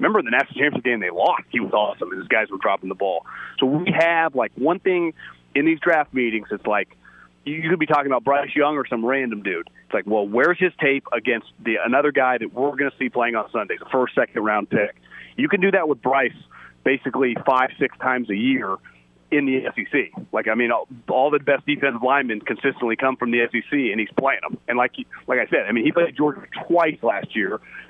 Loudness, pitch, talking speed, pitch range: -21 LUFS, 135 Hz, 235 wpm, 120-150 Hz